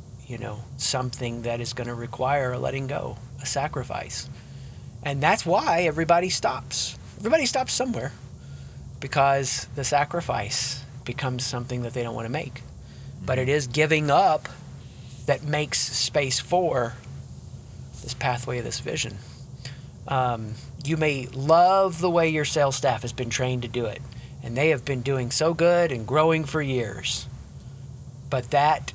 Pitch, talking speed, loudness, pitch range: 130 Hz, 155 wpm, -24 LUFS, 125-150 Hz